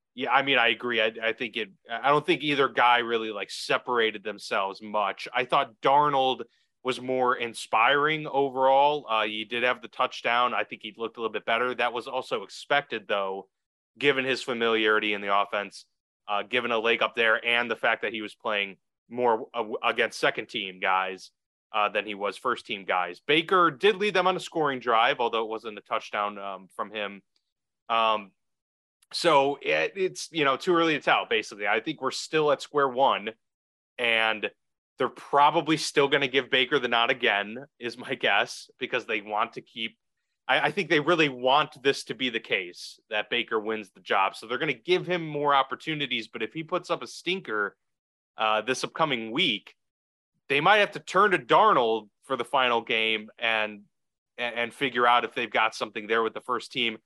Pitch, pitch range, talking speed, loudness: 120 Hz, 110-145 Hz, 200 wpm, -26 LUFS